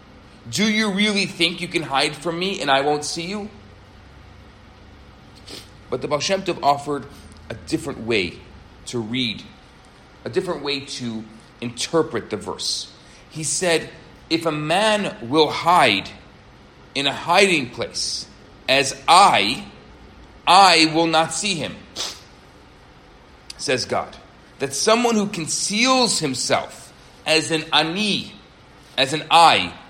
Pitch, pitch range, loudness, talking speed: 155 Hz, 125-175 Hz, -19 LUFS, 125 wpm